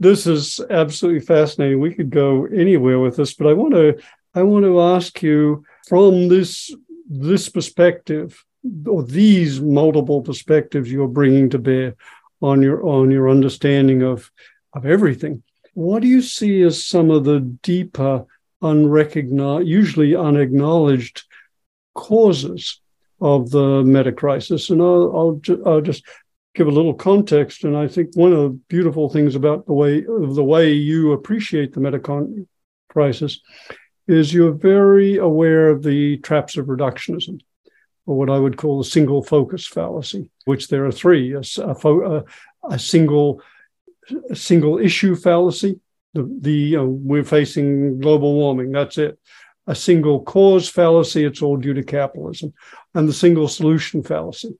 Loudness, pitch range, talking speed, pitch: -16 LUFS, 140-175 Hz, 155 wpm, 150 Hz